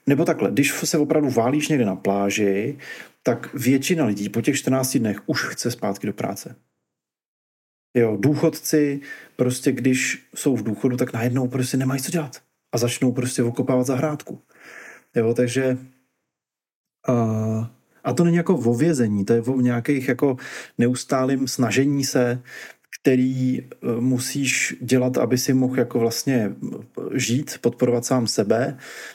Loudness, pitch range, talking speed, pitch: -22 LUFS, 120-140 Hz, 140 wpm, 130 Hz